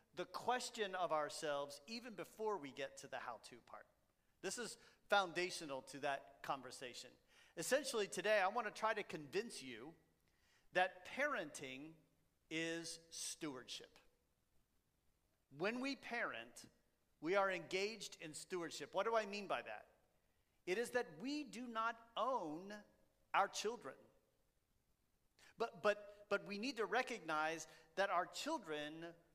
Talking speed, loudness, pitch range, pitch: 135 wpm, -44 LUFS, 155-225 Hz, 185 Hz